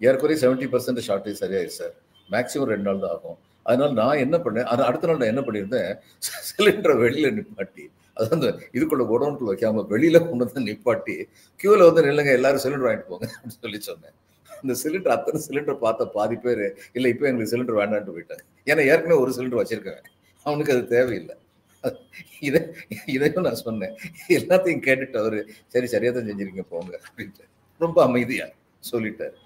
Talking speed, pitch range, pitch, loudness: 160 wpm, 110-165 Hz, 125 Hz, -22 LUFS